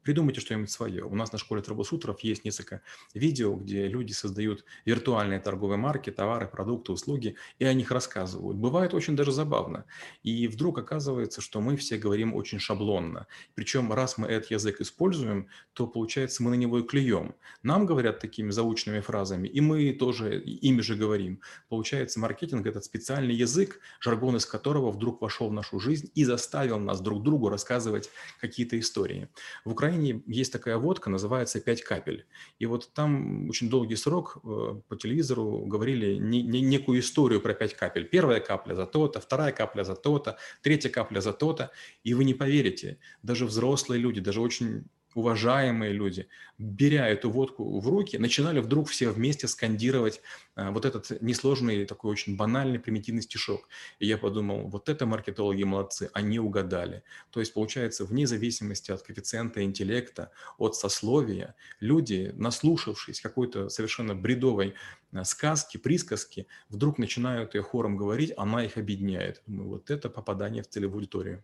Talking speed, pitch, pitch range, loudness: 155 wpm, 115 Hz, 105-130 Hz, -29 LUFS